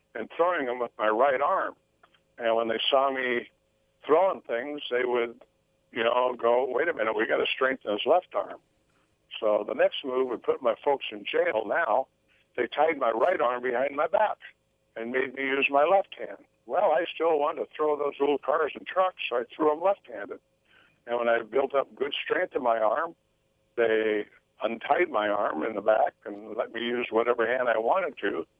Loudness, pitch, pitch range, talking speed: -27 LUFS, 125 Hz, 115-145 Hz, 205 wpm